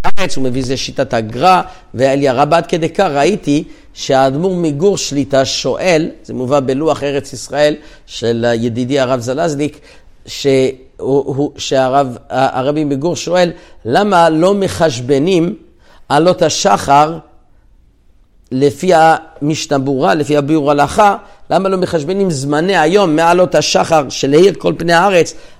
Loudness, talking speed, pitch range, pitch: -13 LUFS, 115 wpm, 135-170 Hz, 145 Hz